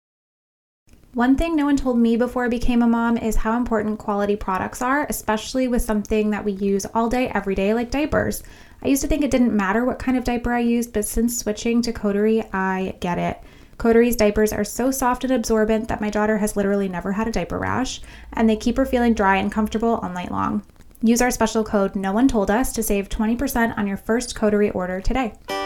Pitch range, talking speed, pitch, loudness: 205-240 Hz, 220 wpm, 225 Hz, -21 LUFS